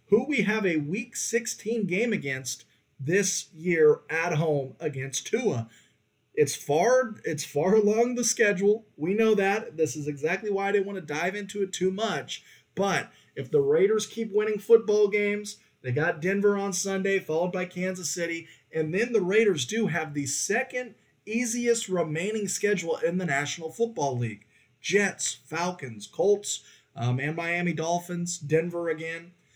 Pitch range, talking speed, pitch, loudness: 160-215 Hz, 160 wpm, 185 Hz, -27 LUFS